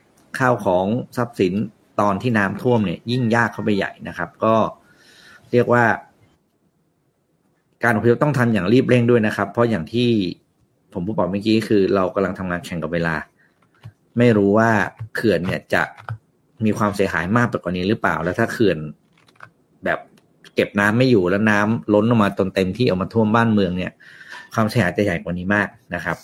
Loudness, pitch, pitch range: -19 LUFS, 105 Hz, 95-120 Hz